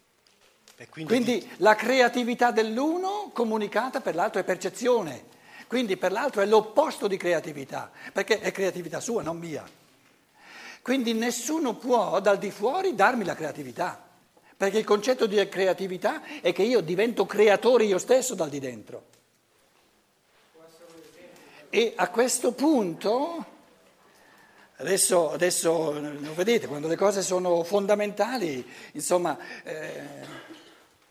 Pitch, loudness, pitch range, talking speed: 210 Hz, -25 LUFS, 180-245 Hz, 115 wpm